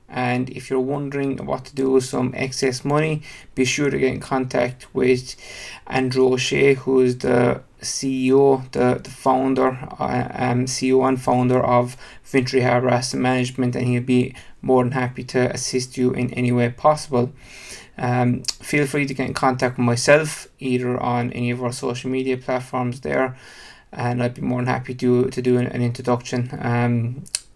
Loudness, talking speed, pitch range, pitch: -21 LUFS, 175 wpm, 125-130 Hz, 130 Hz